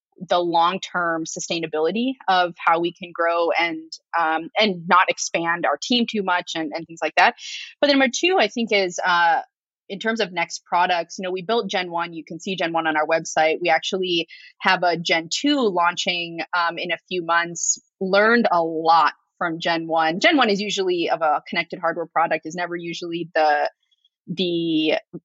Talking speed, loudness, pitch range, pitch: 195 wpm, -21 LUFS, 165-195 Hz, 175 Hz